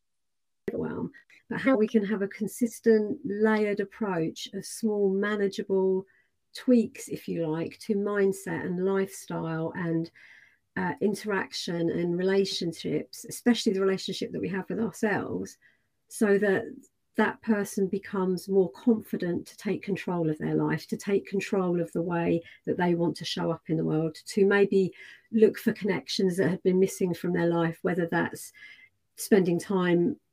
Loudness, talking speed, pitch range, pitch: -28 LUFS, 155 wpm, 175-210 Hz, 195 Hz